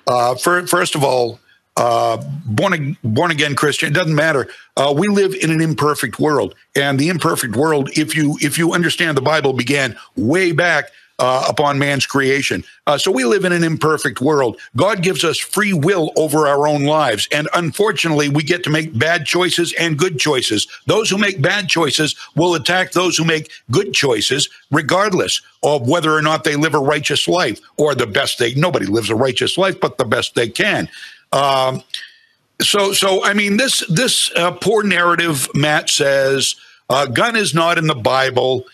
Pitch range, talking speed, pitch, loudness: 140-175 Hz, 190 wpm, 155 Hz, -16 LUFS